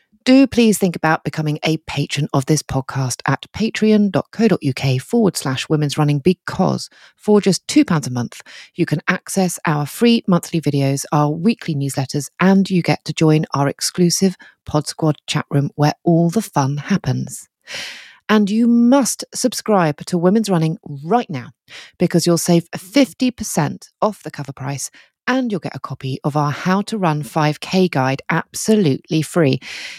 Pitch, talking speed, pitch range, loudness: 165 Hz, 160 wpm, 145-205 Hz, -18 LUFS